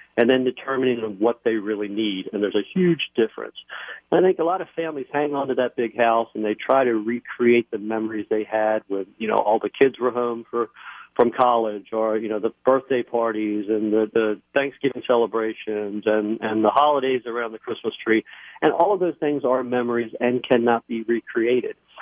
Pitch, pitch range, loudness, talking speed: 120 Hz, 110-130 Hz, -22 LUFS, 200 wpm